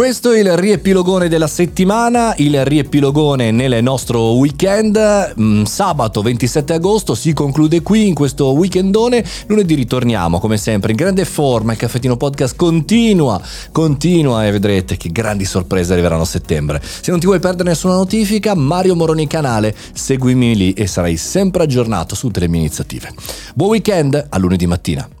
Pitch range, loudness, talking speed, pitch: 110-185 Hz, -14 LUFS, 155 wpm, 145 Hz